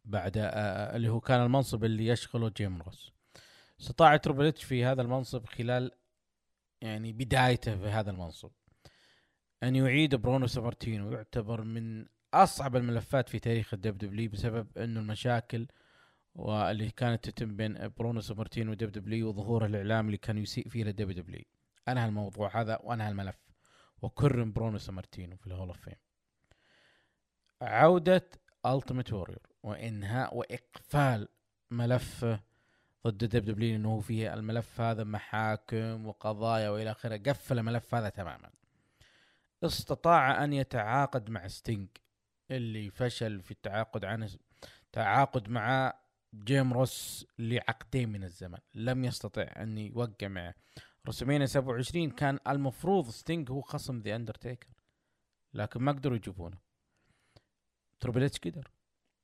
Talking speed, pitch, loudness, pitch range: 125 wpm, 115 Hz, -32 LUFS, 105-125 Hz